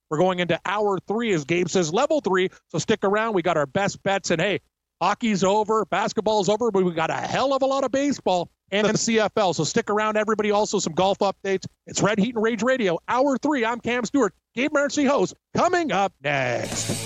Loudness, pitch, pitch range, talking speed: -23 LUFS, 205 Hz, 185-230 Hz, 220 wpm